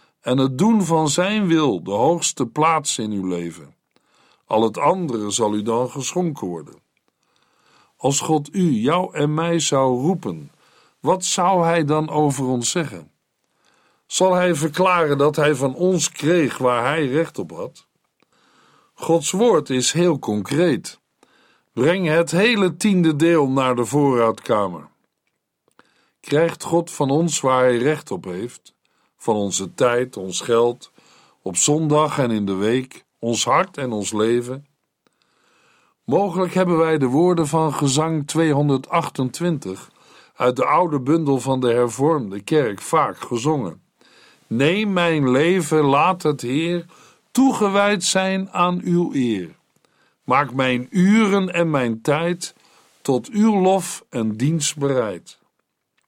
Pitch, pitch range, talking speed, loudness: 155 Hz, 130-175 Hz, 135 wpm, -19 LUFS